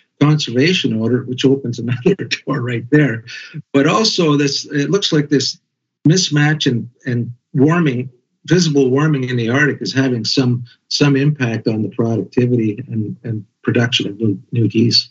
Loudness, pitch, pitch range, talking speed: -16 LUFS, 130 Hz, 120-145 Hz, 155 wpm